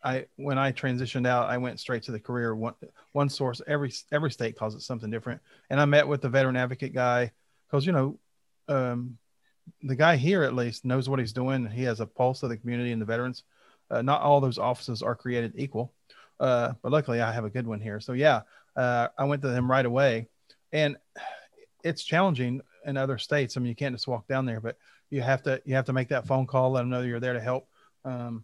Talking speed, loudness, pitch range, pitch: 235 wpm, -28 LUFS, 120-140 Hz, 130 Hz